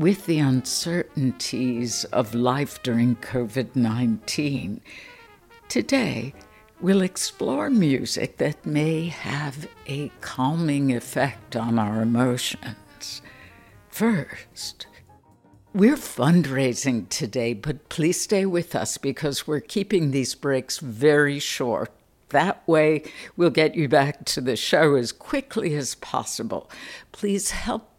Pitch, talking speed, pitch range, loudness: 145 Hz, 110 wpm, 125-170 Hz, -24 LUFS